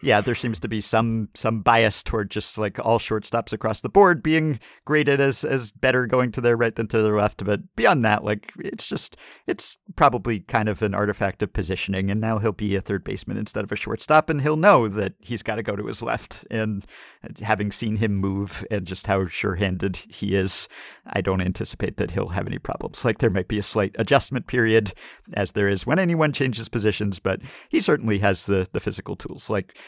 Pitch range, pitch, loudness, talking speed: 100-120 Hz, 110 Hz, -23 LUFS, 220 wpm